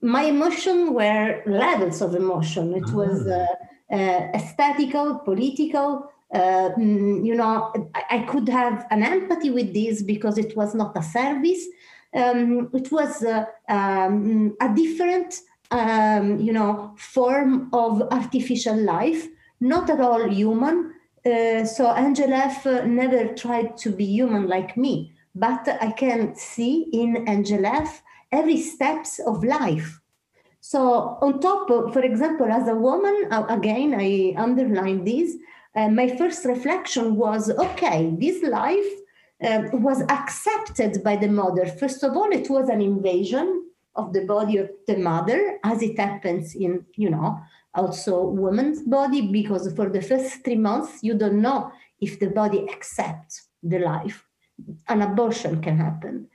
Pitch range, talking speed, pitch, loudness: 200-275 Hz, 145 wpm, 230 Hz, -22 LUFS